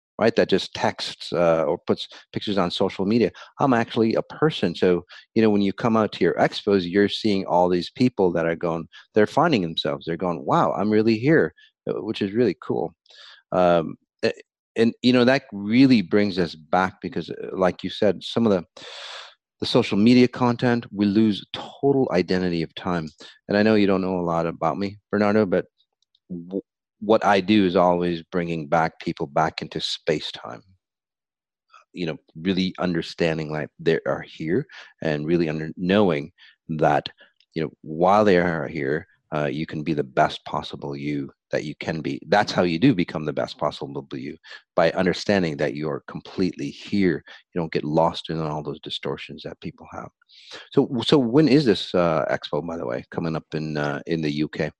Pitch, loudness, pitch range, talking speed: 95 Hz, -23 LUFS, 85-105 Hz, 190 wpm